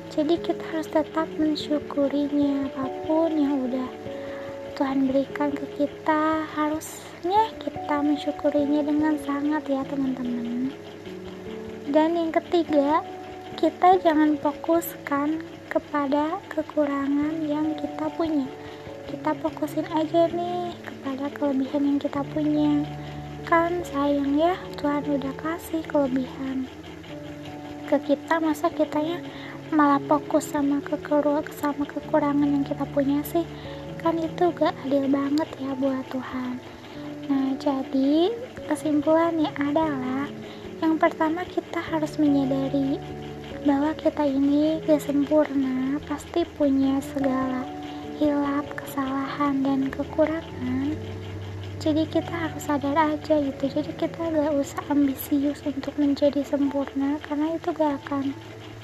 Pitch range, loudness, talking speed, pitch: 275-315 Hz, -25 LUFS, 110 wpm, 290 Hz